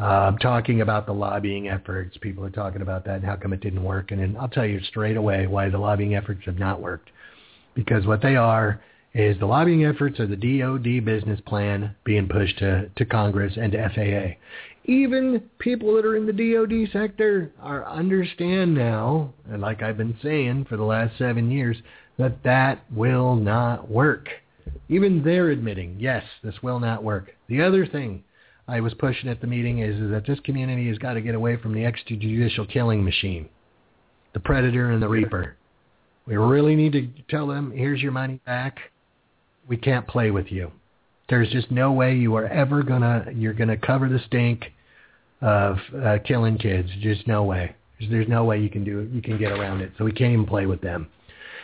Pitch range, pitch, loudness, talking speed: 105-130 Hz, 115 Hz, -23 LUFS, 200 wpm